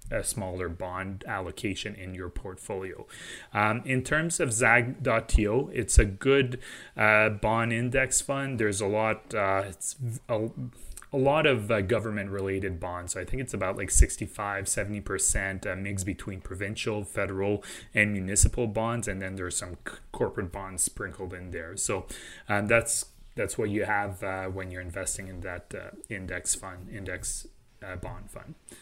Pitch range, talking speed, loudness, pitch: 95-115 Hz, 160 wpm, -28 LUFS, 100 Hz